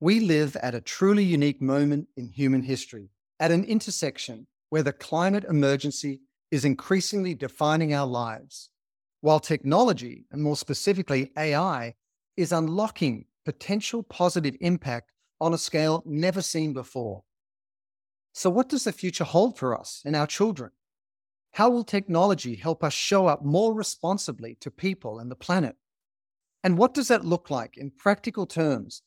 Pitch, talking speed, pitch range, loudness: 155 Hz, 150 wpm, 135-190 Hz, -26 LUFS